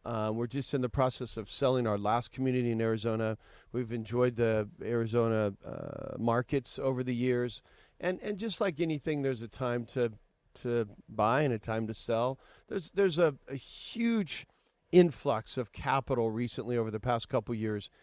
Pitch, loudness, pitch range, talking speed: 120 Hz, -32 LUFS, 115-135 Hz, 185 wpm